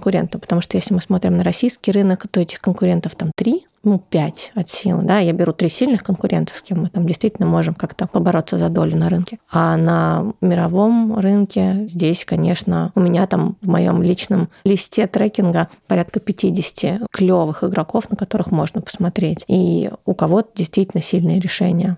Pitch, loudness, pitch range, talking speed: 185 Hz, -18 LUFS, 175-200 Hz, 170 wpm